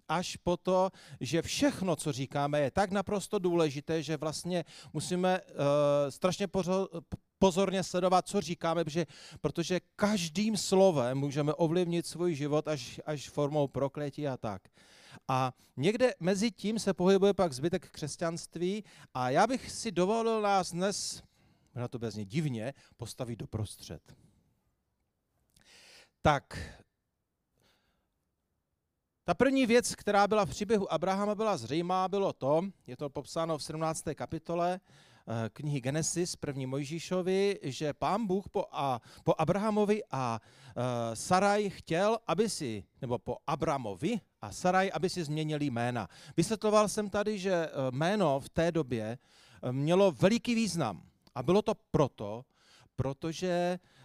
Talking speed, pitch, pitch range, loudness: 125 wpm, 165 Hz, 140-190 Hz, -32 LUFS